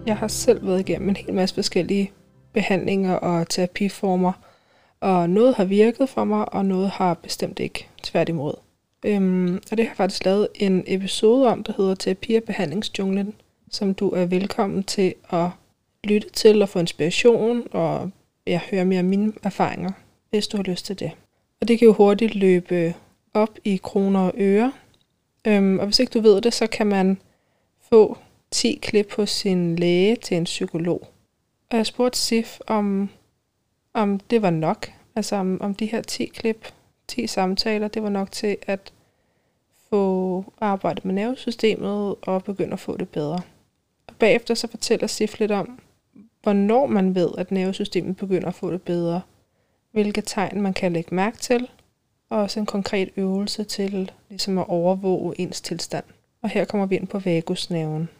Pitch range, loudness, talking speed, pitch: 185-215 Hz, -22 LUFS, 170 wpm, 195 Hz